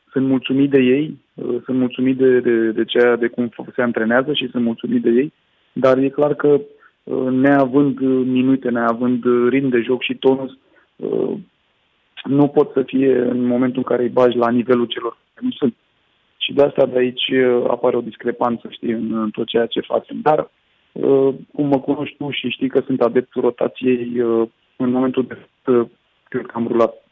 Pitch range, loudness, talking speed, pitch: 120-135 Hz, -18 LUFS, 195 wpm, 125 Hz